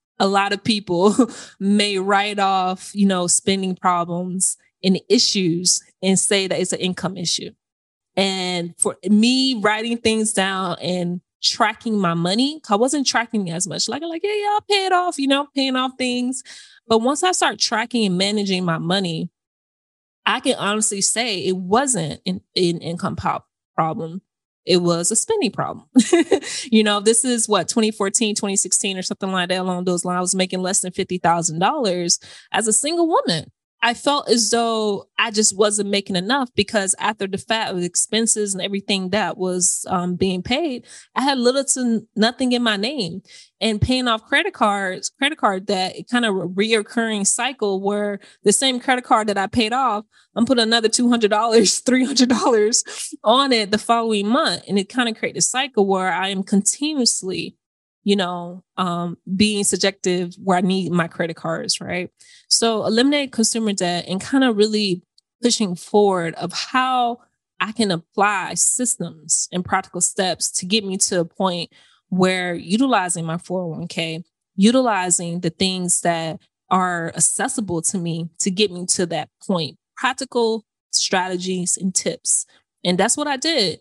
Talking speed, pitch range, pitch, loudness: 170 wpm, 185-235 Hz, 200 Hz, -19 LUFS